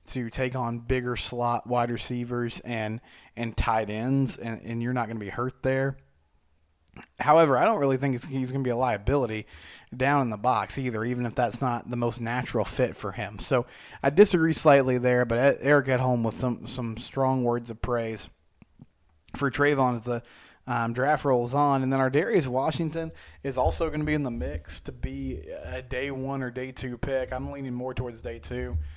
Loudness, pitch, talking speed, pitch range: -27 LUFS, 125 Hz, 205 wpm, 115-135 Hz